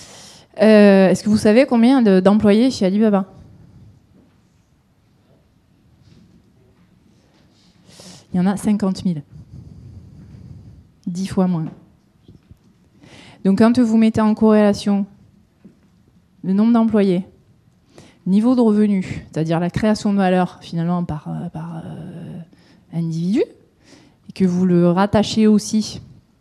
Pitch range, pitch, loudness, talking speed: 175-215 Hz, 195 Hz, -16 LUFS, 105 wpm